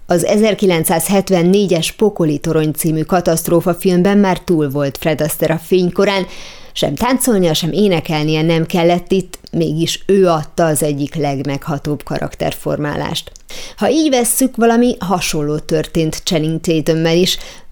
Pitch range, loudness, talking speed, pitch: 160-190 Hz, -15 LUFS, 120 wpm, 170 Hz